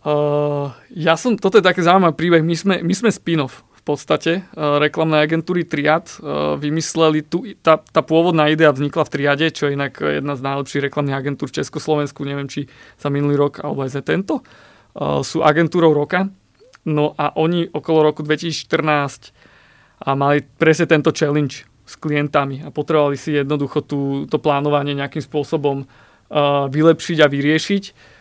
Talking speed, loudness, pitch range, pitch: 165 wpm, -18 LUFS, 145-160 Hz, 150 Hz